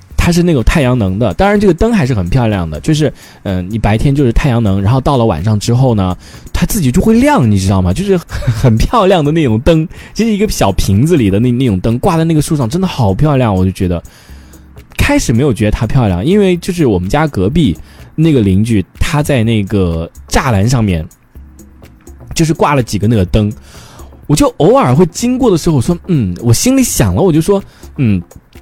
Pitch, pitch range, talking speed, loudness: 120 Hz, 95-165 Hz, 310 characters per minute, -11 LUFS